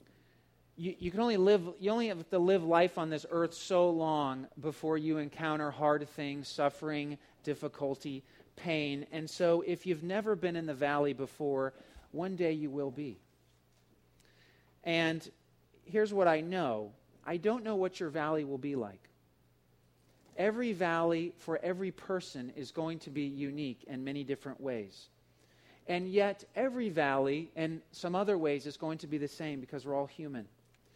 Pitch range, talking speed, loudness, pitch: 140-175 Hz, 165 wpm, -34 LUFS, 155 Hz